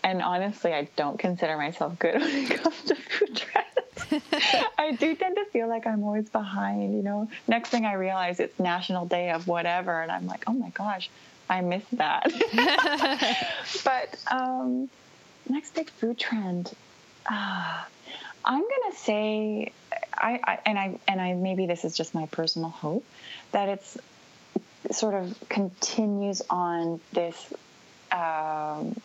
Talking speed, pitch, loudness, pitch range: 155 wpm, 205 Hz, -28 LUFS, 175-255 Hz